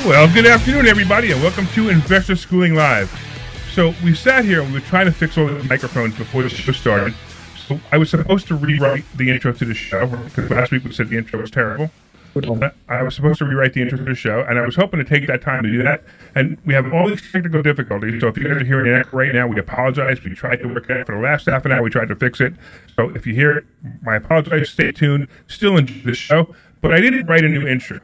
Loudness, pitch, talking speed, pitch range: -16 LUFS, 135 Hz, 265 wpm, 125-160 Hz